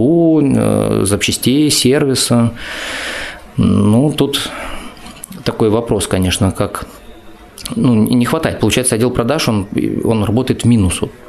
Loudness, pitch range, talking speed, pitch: -14 LUFS, 105-130 Hz, 100 wpm, 120 Hz